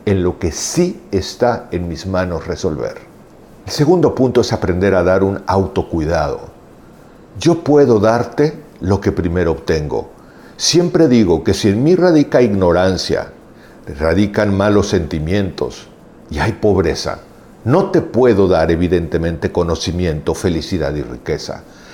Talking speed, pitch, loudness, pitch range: 130 wpm, 95 Hz, -15 LUFS, 90-115 Hz